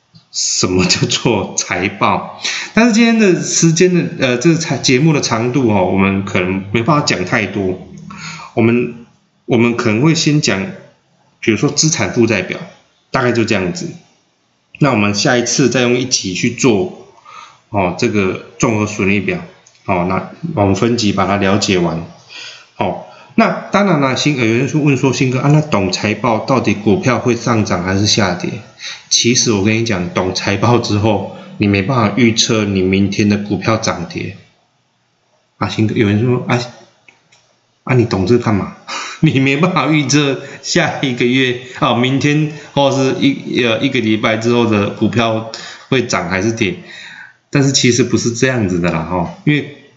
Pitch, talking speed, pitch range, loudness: 120 Hz, 245 characters per minute, 105-140 Hz, -14 LUFS